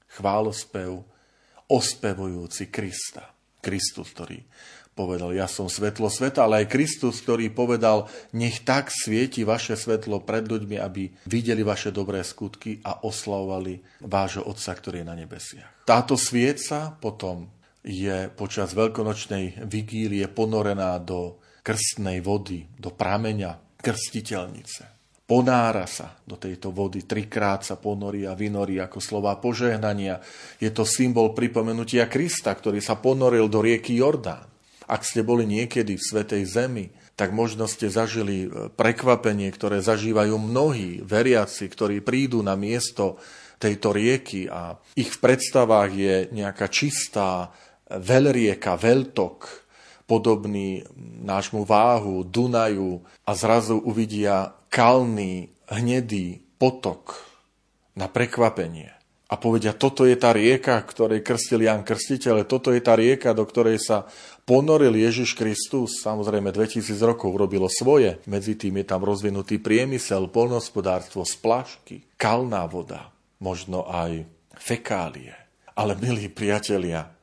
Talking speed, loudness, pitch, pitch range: 120 wpm, -23 LUFS, 105 Hz, 95-115 Hz